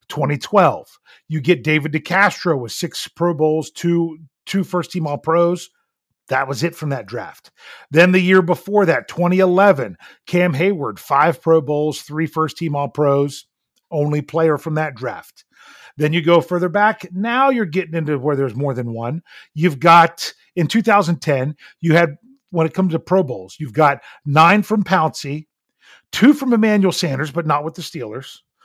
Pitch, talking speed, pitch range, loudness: 165 Hz, 170 wpm, 150-180 Hz, -17 LUFS